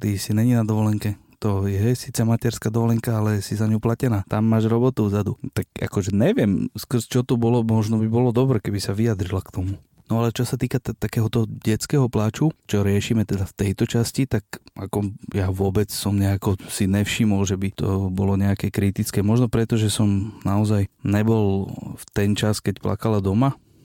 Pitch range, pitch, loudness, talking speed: 100-115 Hz, 110 Hz, -22 LUFS, 190 wpm